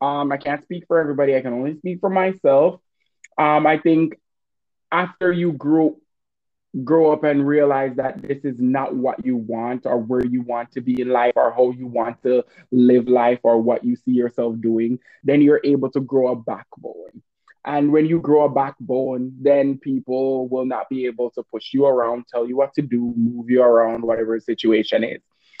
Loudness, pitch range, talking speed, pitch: -19 LUFS, 120-145 Hz, 200 wpm, 130 Hz